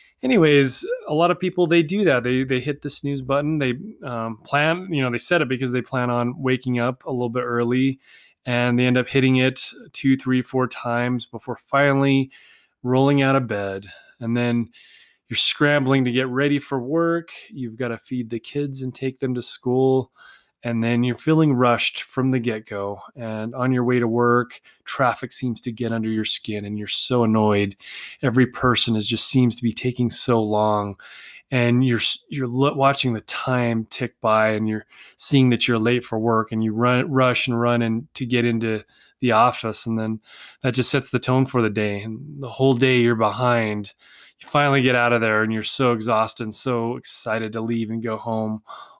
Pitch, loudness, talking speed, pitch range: 125 Hz, -21 LUFS, 200 wpm, 115-130 Hz